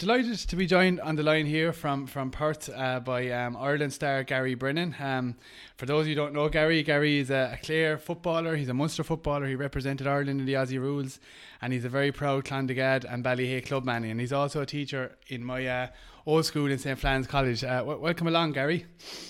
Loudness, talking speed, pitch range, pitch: -28 LUFS, 225 wpm, 130-155 Hz, 140 Hz